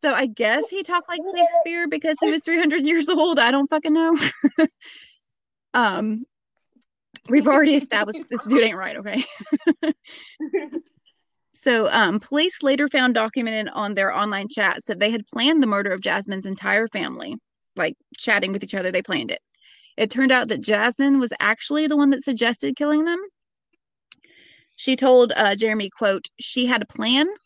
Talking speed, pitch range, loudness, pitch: 165 wpm, 220-315 Hz, -20 LUFS, 270 Hz